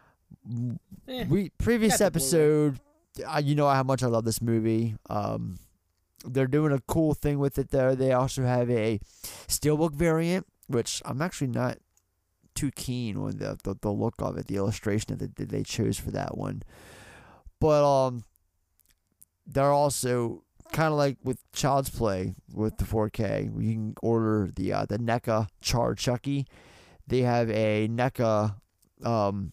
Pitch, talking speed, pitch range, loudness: 120 Hz, 155 wpm, 105-140 Hz, -27 LUFS